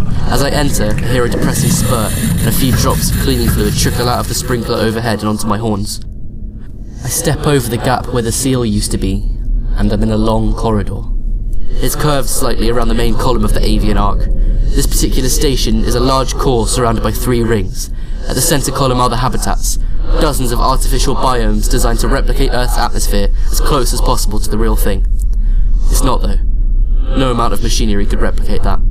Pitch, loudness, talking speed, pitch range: 110 Hz, -15 LUFS, 205 wpm, 105-125 Hz